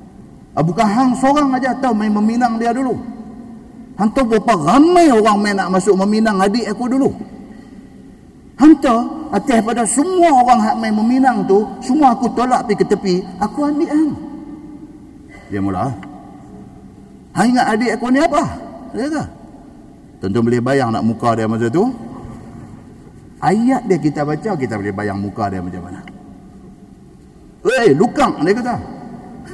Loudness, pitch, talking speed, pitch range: -15 LUFS, 225 Hz, 150 wpm, 190-260 Hz